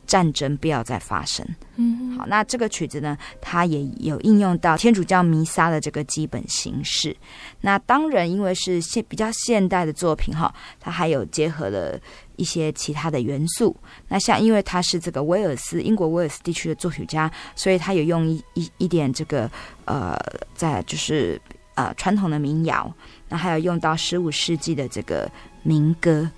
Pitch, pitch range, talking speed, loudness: 165 Hz, 155-185 Hz, 270 characters per minute, -22 LUFS